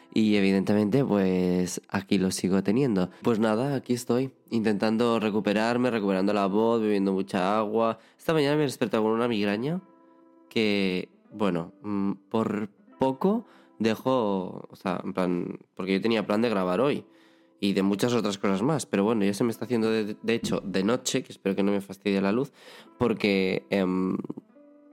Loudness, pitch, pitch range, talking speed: -26 LUFS, 105 Hz, 95-115 Hz, 170 wpm